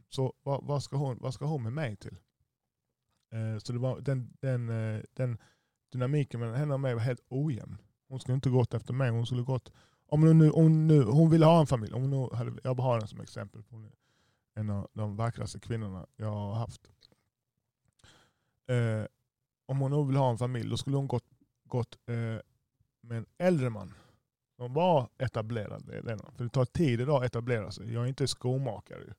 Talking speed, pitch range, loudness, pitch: 195 wpm, 115-135 Hz, -30 LUFS, 125 Hz